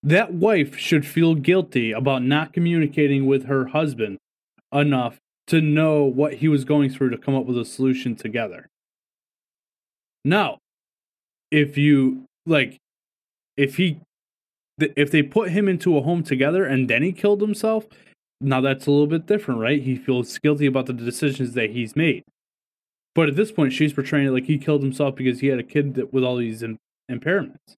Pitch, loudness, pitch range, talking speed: 145 Hz, -21 LUFS, 130-155 Hz, 180 wpm